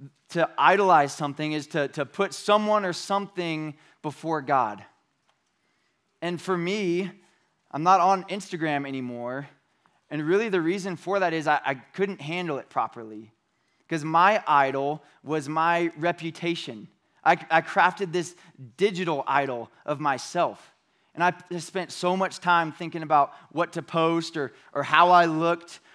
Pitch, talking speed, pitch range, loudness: 165 Hz, 145 wpm, 145-180 Hz, -25 LUFS